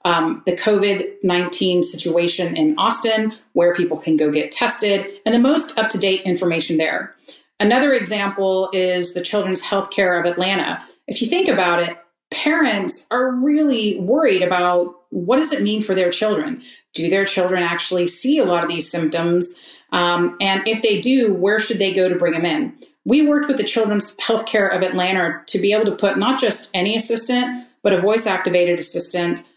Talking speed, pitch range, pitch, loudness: 180 wpm, 175-225 Hz, 195 Hz, -18 LUFS